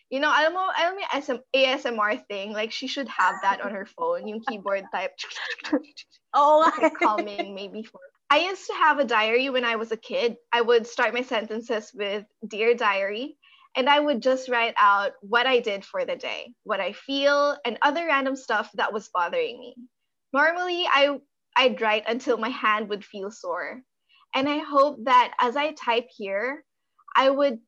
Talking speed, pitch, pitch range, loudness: 185 wpm, 250 Hz, 220-290 Hz, -24 LUFS